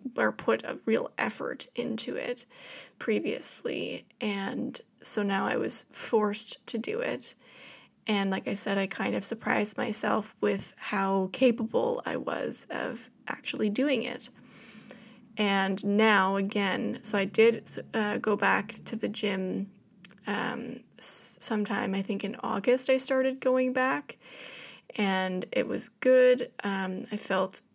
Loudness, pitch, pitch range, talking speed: -29 LUFS, 215 Hz, 195-245 Hz, 140 wpm